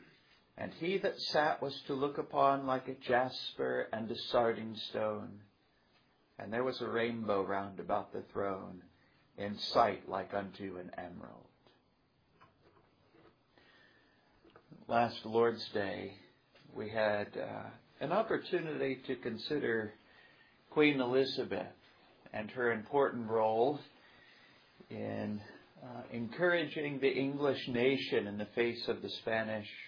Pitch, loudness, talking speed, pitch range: 120 Hz, -35 LUFS, 115 wpm, 105-135 Hz